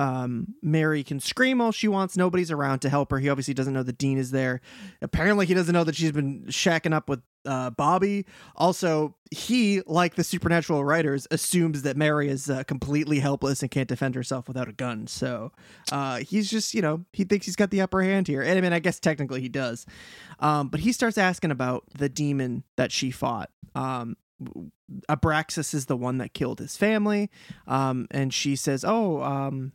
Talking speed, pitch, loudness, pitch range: 200 wpm, 150 Hz, -26 LUFS, 135-185 Hz